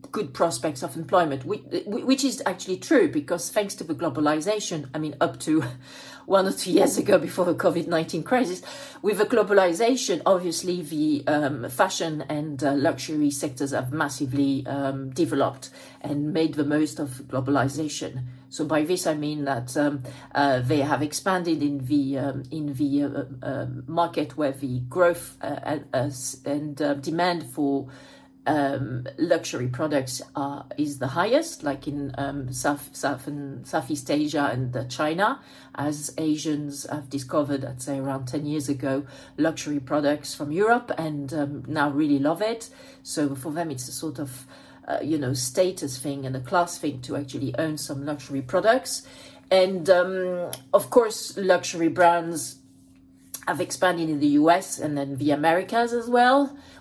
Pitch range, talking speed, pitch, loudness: 140-175 Hz, 160 wpm, 150 Hz, -25 LUFS